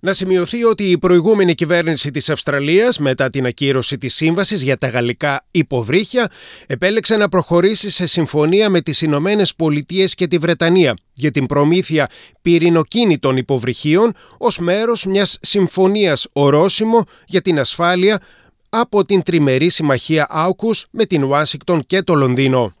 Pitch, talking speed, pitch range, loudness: 170 Hz, 140 wpm, 145-195 Hz, -15 LUFS